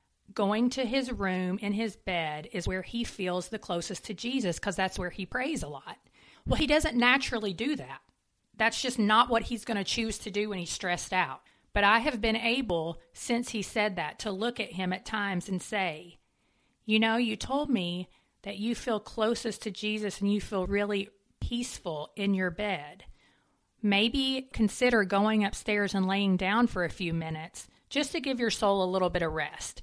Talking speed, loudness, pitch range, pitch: 200 wpm, -30 LUFS, 185-230 Hz, 205 Hz